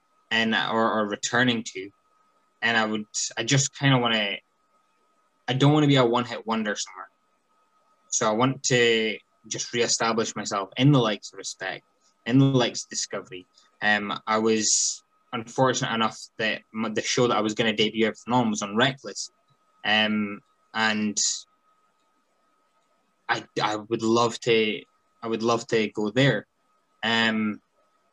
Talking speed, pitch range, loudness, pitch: 160 wpm, 110-140 Hz, -24 LUFS, 115 Hz